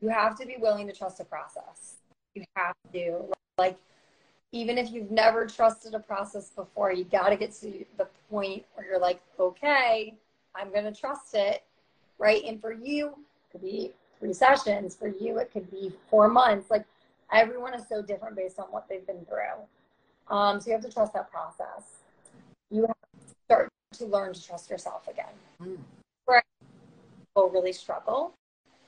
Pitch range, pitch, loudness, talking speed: 195-225 Hz, 210 Hz, -28 LUFS, 175 wpm